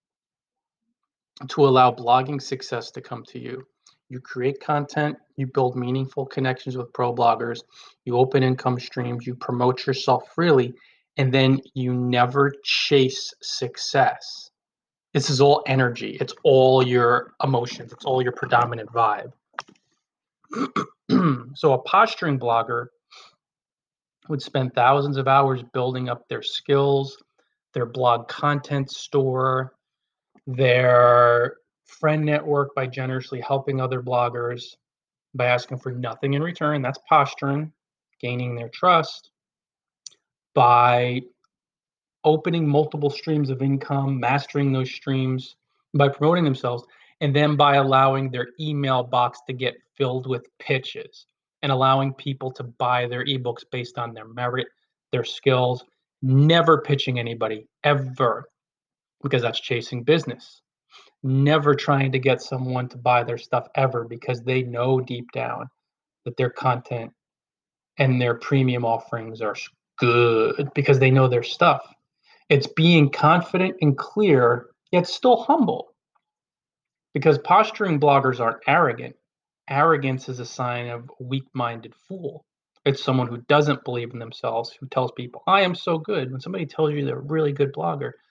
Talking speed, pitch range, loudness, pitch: 135 wpm, 125-145 Hz, -22 LUFS, 130 Hz